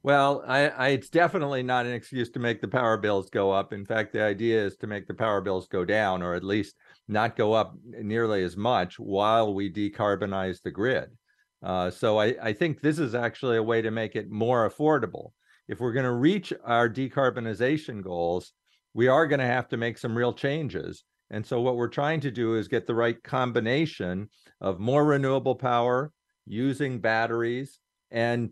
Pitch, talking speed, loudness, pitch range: 120 Hz, 195 wpm, -27 LUFS, 105-135 Hz